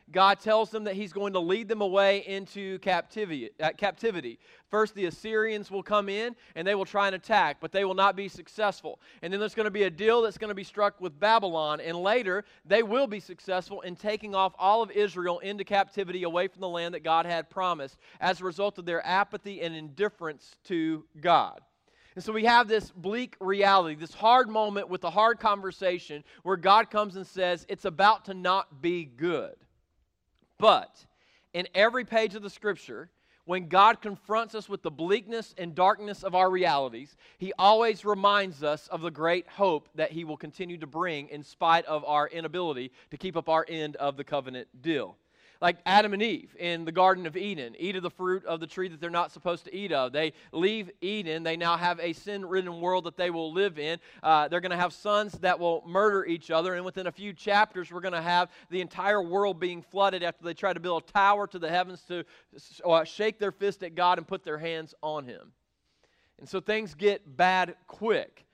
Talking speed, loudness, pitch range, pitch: 215 wpm, -28 LUFS, 170-205 Hz, 185 Hz